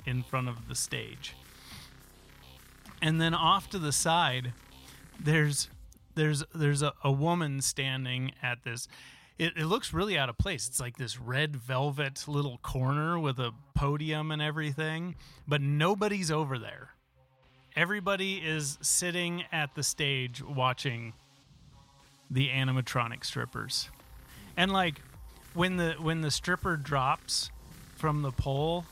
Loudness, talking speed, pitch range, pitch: -31 LUFS, 135 wpm, 130-160 Hz, 140 Hz